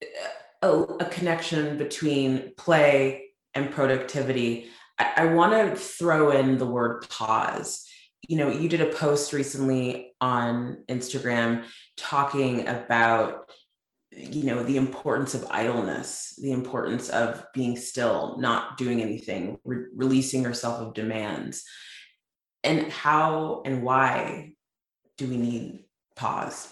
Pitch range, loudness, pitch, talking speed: 120-150 Hz, -26 LUFS, 130 Hz, 120 wpm